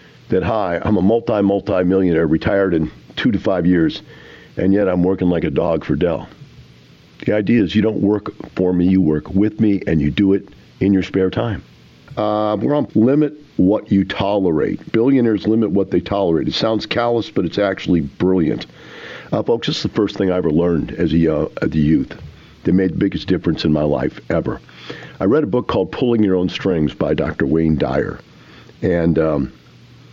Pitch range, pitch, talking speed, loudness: 85-105 Hz, 95 Hz, 195 wpm, -17 LUFS